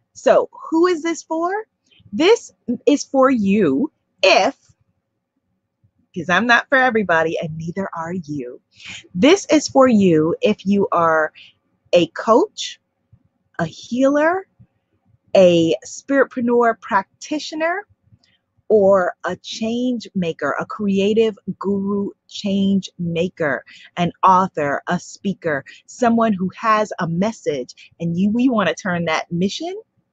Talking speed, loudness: 120 wpm, -18 LUFS